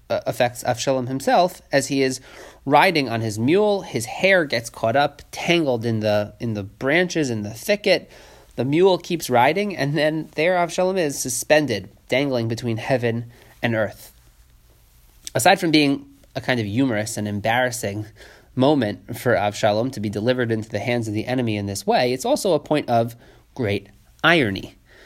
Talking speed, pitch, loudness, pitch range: 170 wpm, 125 Hz, -21 LUFS, 110-145 Hz